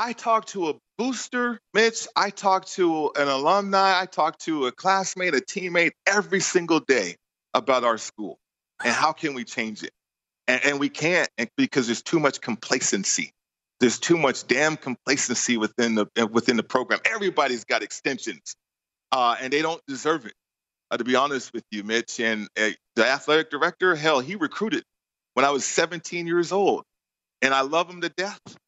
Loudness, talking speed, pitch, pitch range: -23 LUFS, 180 wpm, 160 Hz, 130-190 Hz